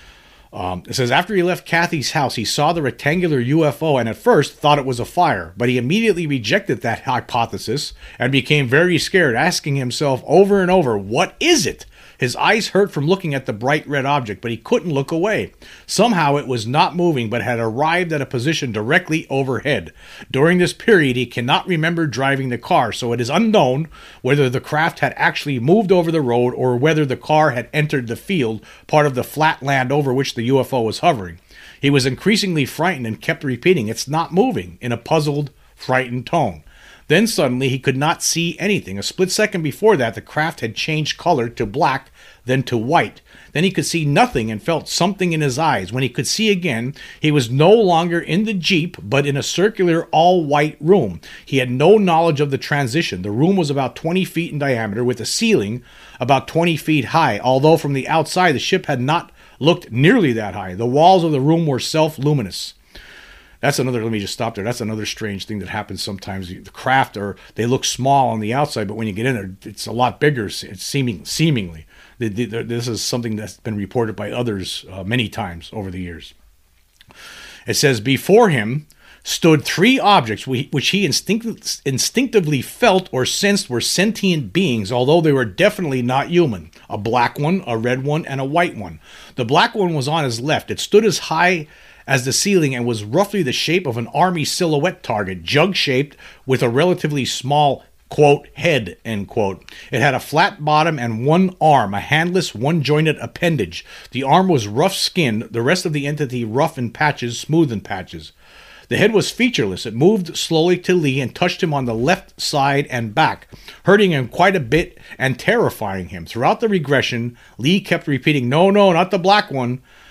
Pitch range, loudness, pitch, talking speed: 120-170 Hz, -17 LUFS, 140 Hz, 200 wpm